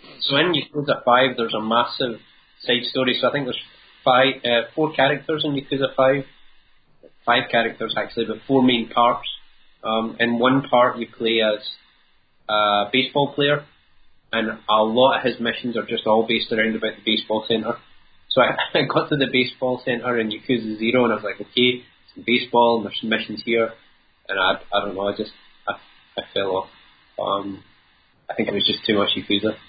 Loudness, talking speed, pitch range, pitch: -21 LUFS, 190 wpm, 110-125 Hz, 115 Hz